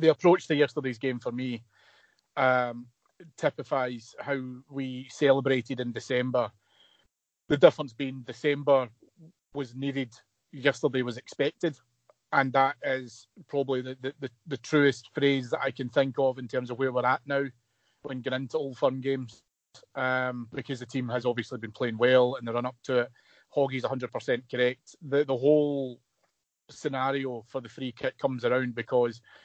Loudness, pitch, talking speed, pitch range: -29 LUFS, 130 Hz, 165 wpm, 125-140 Hz